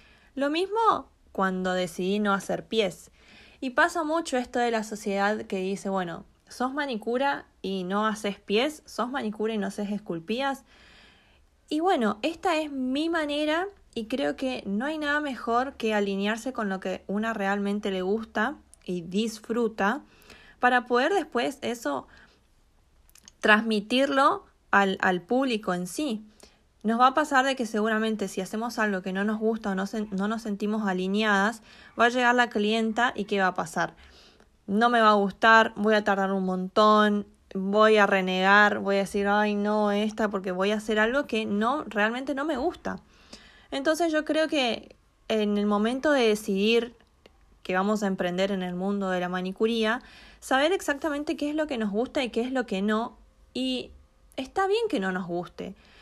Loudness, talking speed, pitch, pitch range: -26 LUFS, 175 wpm, 220 Hz, 200-255 Hz